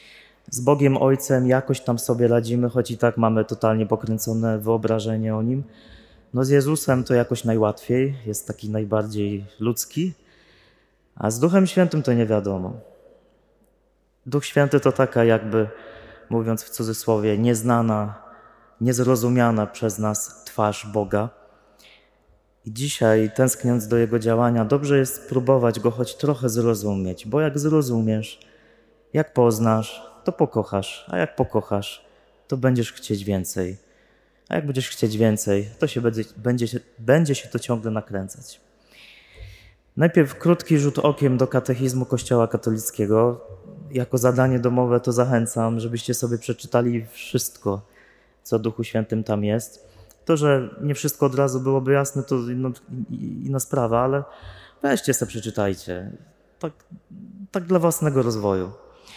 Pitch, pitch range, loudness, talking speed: 120 Hz, 110-135 Hz, -22 LUFS, 135 wpm